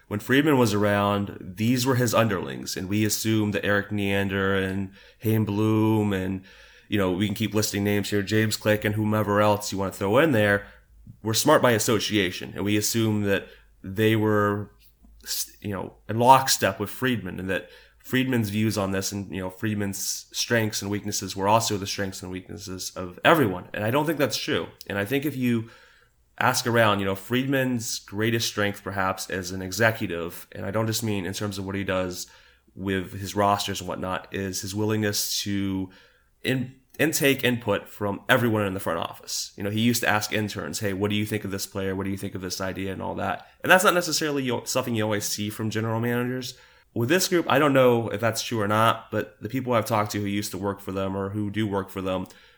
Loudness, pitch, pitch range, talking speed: -25 LUFS, 105 Hz, 100-115 Hz, 215 wpm